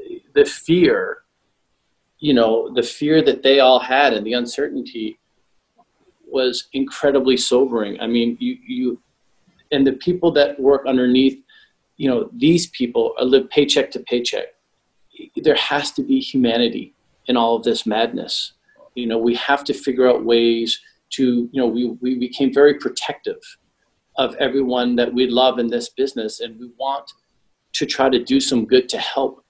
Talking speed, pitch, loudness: 165 wpm, 135 Hz, -18 LUFS